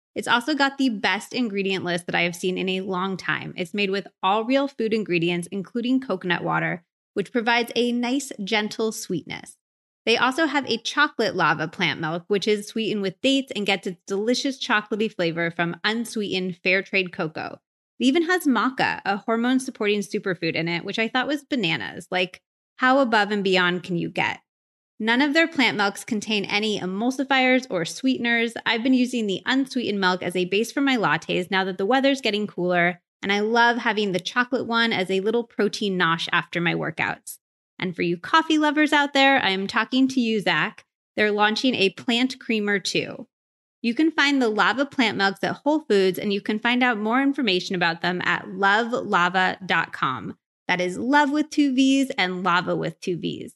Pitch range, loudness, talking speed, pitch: 185-255 Hz, -22 LUFS, 195 wpm, 210 Hz